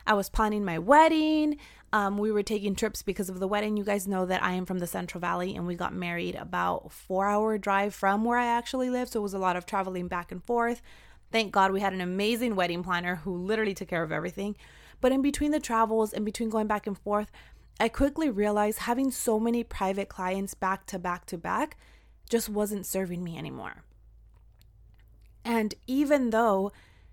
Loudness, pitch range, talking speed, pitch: -28 LUFS, 185-225 Hz, 210 wpm, 205 Hz